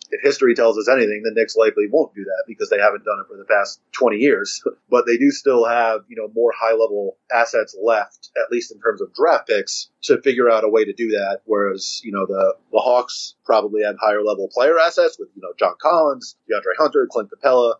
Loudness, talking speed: -18 LUFS, 235 wpm